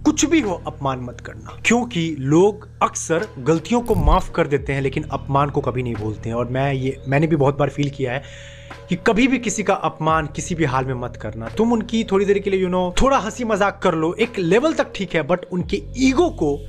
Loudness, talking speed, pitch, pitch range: -20 LUFS, 245 wpm, 160 Hz, 135-200 Hz